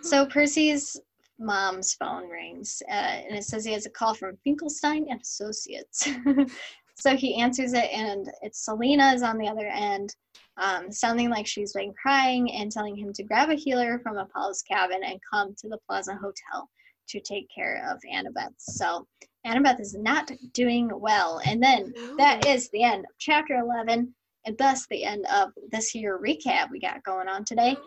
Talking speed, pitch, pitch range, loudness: 180 wpm, 235 Hz, 205-275 Hz, -26 LUFS